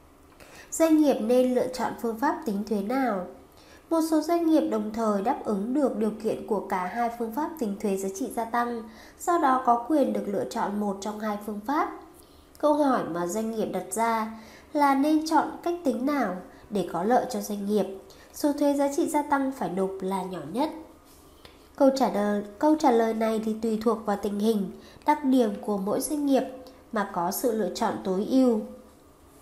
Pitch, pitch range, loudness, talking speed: 235 Hz, 205-285 Hz, -26 LUFS, 205 wpm